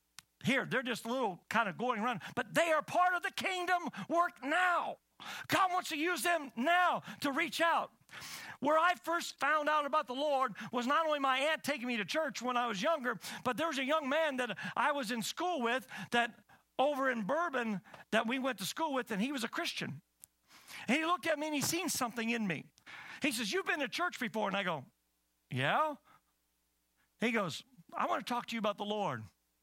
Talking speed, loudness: 220 wpm, -34 LUFS